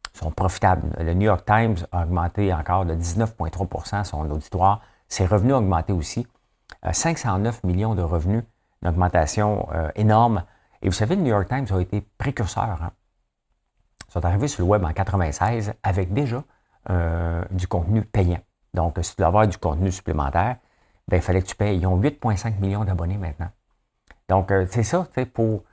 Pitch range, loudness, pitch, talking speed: 90-110 Hz, -23 LUFS, 95 Hz, 175 wpm